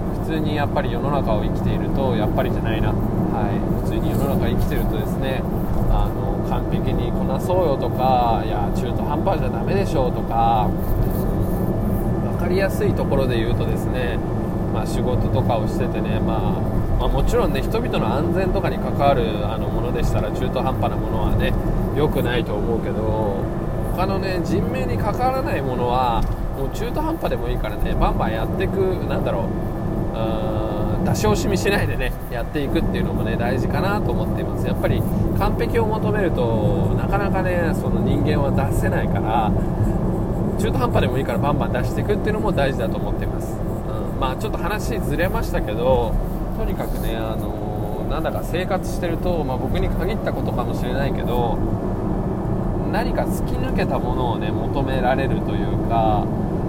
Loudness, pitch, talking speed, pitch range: -22 LUFS, 110 Hz, 375 characters per minute, 105-110 Hz